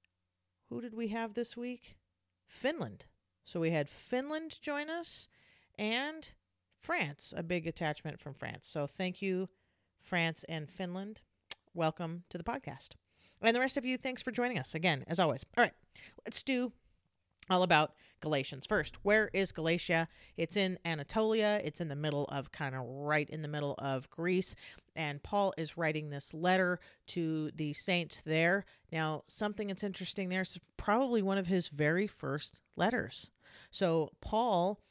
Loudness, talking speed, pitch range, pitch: -35 LUFS, 160 wpm, 150-205 Hz, 170 Hz